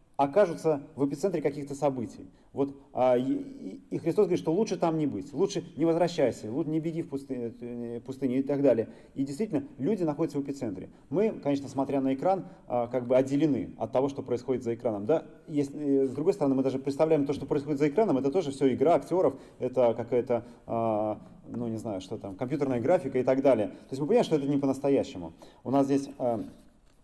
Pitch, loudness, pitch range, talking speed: 140 Hz, -29 LUFS, 130-160 Hz, 195 wpm